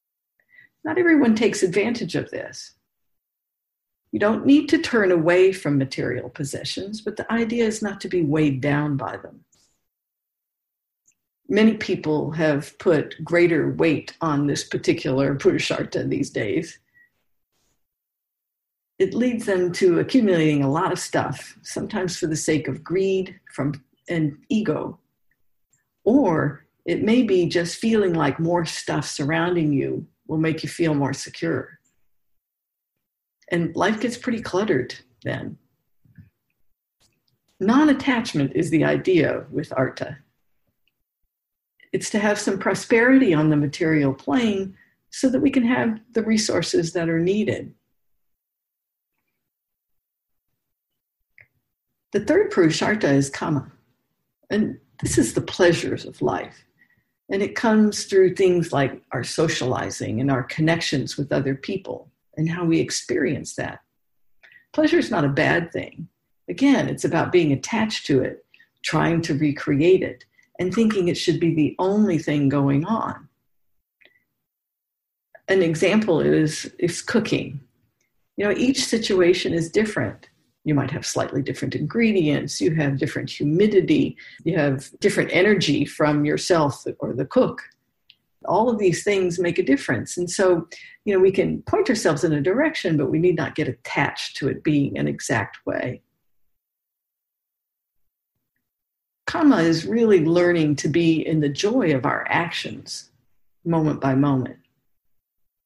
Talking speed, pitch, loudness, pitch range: 135 wpm, 175 Hz, -21 LUFS, 150-215 Hz